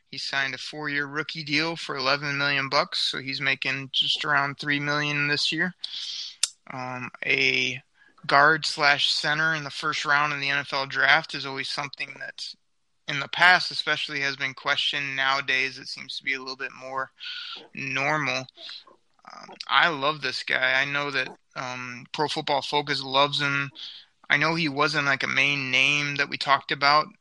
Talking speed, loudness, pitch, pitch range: 175 wpm, -24 LUFS, 145 Hz, 135-150 Hz